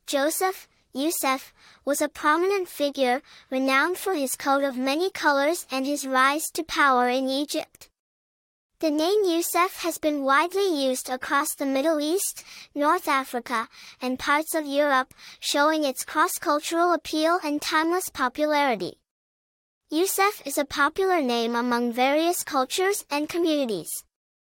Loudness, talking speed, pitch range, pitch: -24 LUFS, 135 wpm, 270-335 Hz, 295 Hz